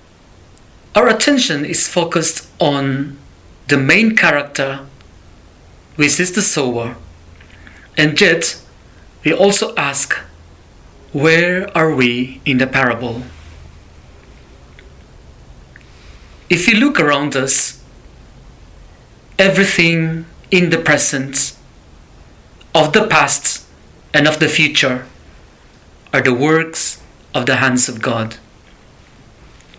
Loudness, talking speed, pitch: -14 LUFS, 95 wpm, 135 Hz